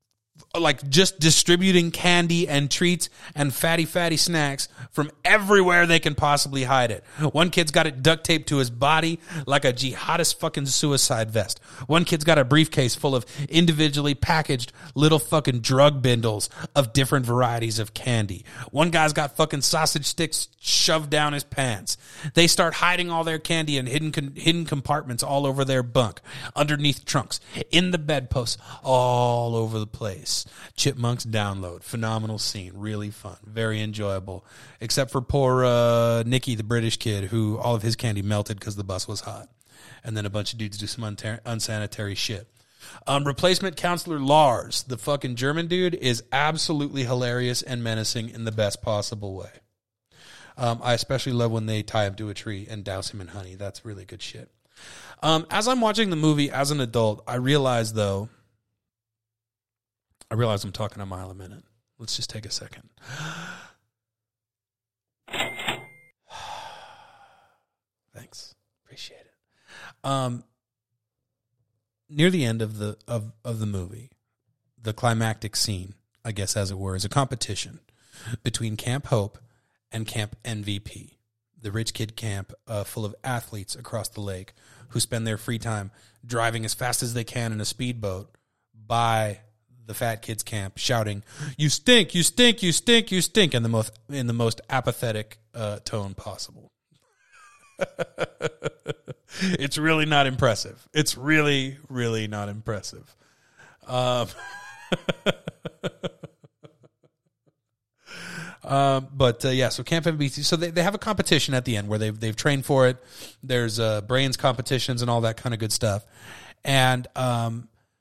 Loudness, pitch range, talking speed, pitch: -24 LUFS, 110-145 Hz, 155 wpm, 120 Hz